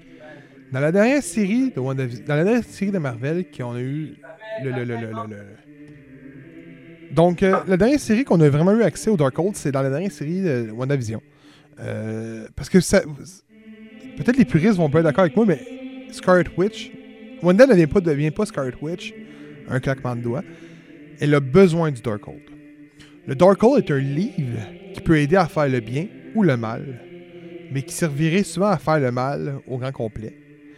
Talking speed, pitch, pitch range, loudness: 190 wpm, 155 Hz, 135-190 Hz, -20 LUFS